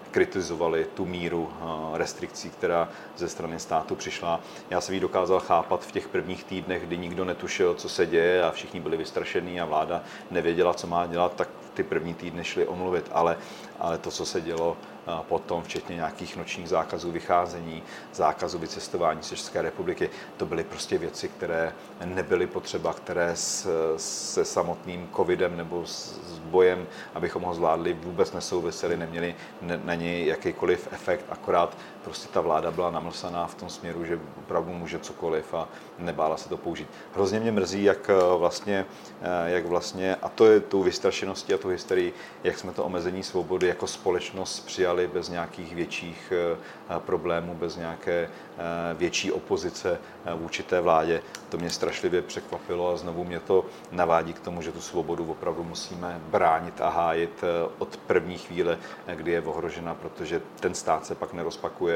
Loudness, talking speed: -28 LUFS, 160 wpm